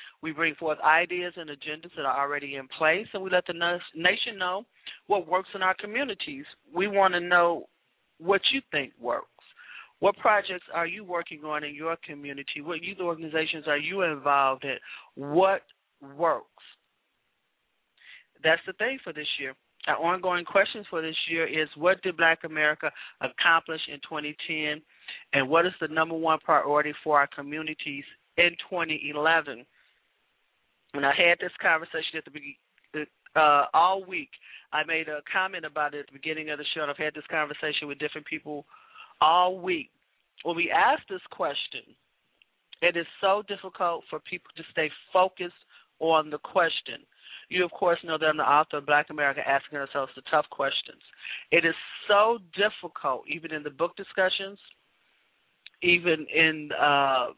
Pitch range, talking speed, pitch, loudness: 150-180 Hz, 165 wpm, 160 Hz, -26 LUFS